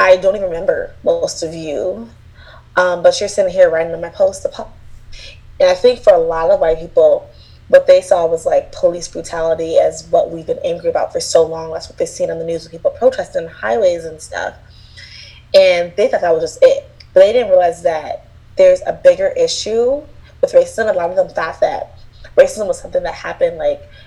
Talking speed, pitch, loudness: 210 wpm, 275 Hz, -15 LUFS